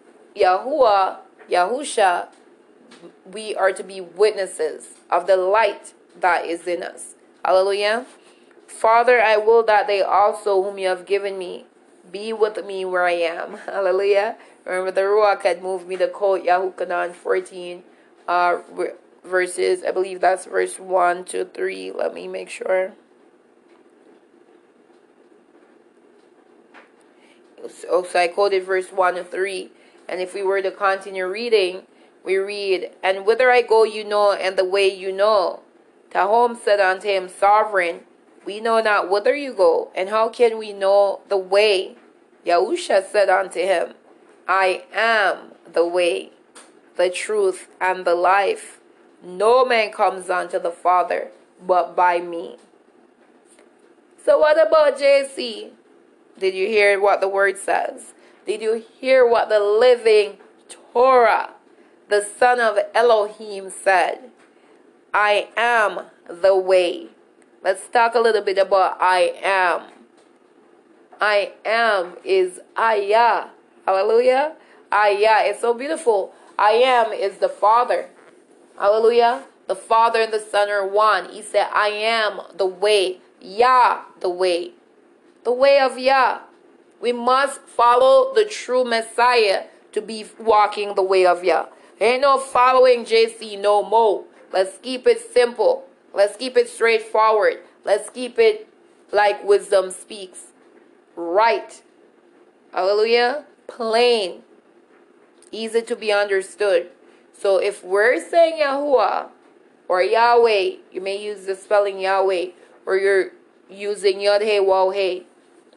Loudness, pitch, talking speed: -19 LUFS, 215 Hz, 135 wpm